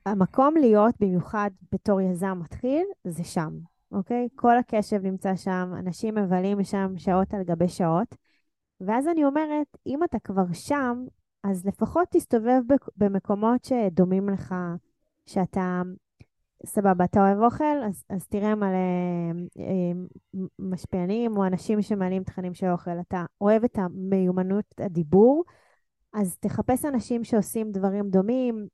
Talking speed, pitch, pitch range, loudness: 125 wpm, 200 Hz, 185-235 Hz, -25 LUFS